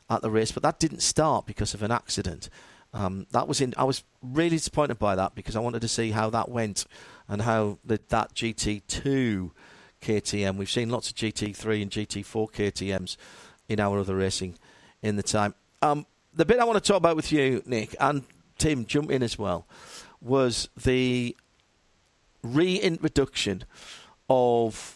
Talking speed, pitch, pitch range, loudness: 170 wpm, 110 Hz, 100-130 Hz, -27 LUFS